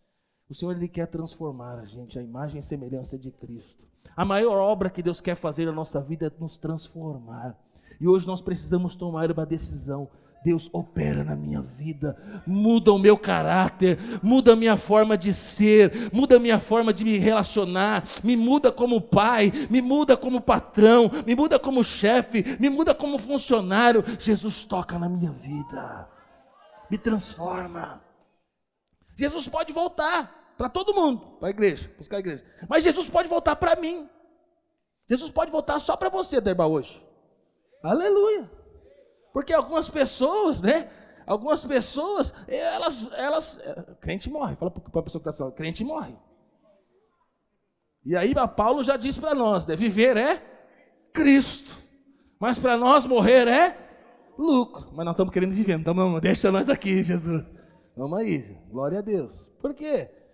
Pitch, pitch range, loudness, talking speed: 215 Hz, 170-275 Hz, -23 LUFS, 160 wpm